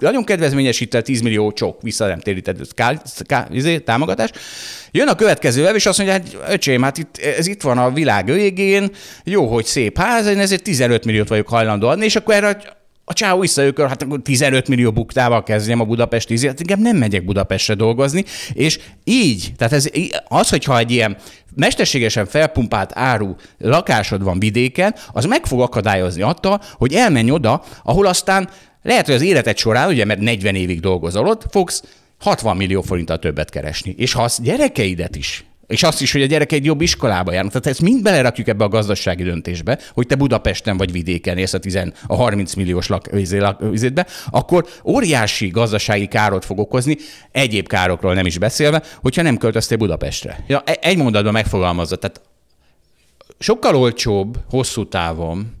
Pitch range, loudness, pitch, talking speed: 100-155 Hz, -16 LUFS, 120 Hz, 175 wpm